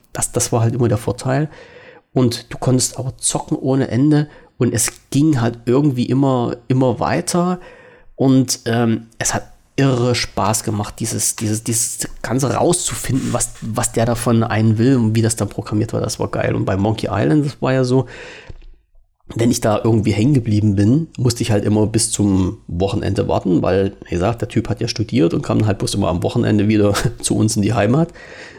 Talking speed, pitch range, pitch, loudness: 195 wpm, 105-130 Hz, 120 Hz, -17 LUFS